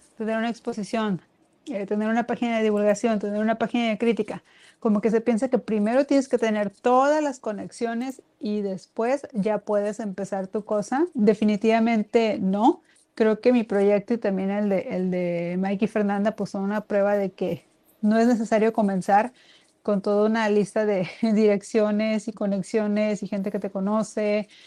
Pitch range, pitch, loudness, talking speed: 205-230 Hz, 215 Hz, -24 LUFS, 170 wpm